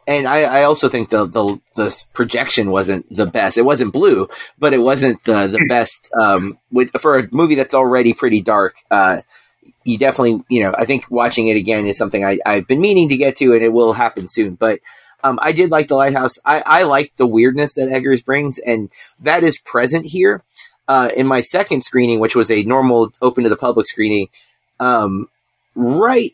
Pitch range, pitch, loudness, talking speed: 110-135 Hz, 125 Hz, -15 LUFS, 205 wpm